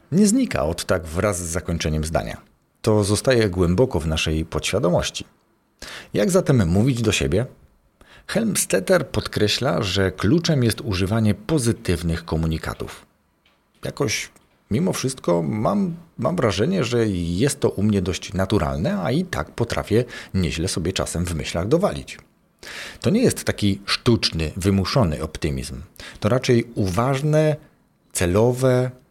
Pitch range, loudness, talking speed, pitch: 85-125 Hz, -21 LUFS, 125 wpm, 100 Hz